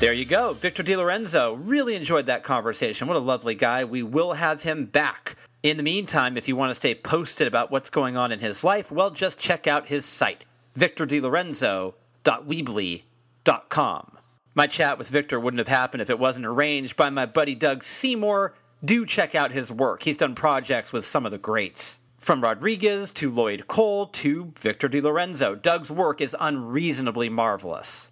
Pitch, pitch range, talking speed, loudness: 145 Hz, 125-175 Hz, 180 wpm, -24 LUFS